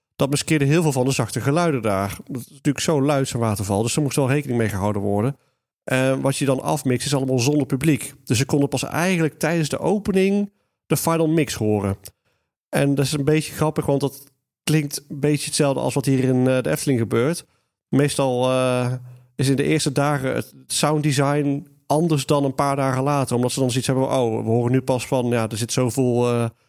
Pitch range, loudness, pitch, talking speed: 125-145 Hz, -21 LUFS, 135 Hz, 220 wpm